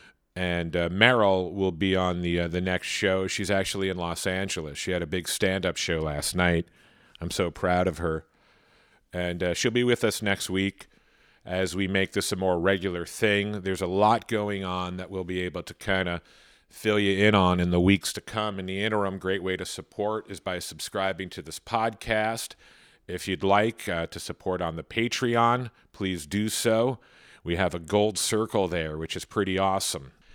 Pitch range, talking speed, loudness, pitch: 90-105 Hz, 200 wpm, -27 LUFS, 95 Hz